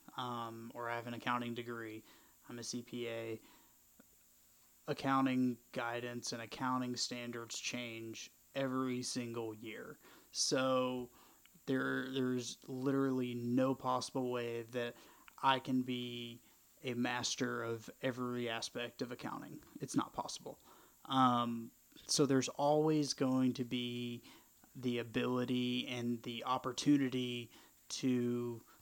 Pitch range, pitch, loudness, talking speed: 120-130 Hz, 120 Hz, -38 LUFS, 110 wpm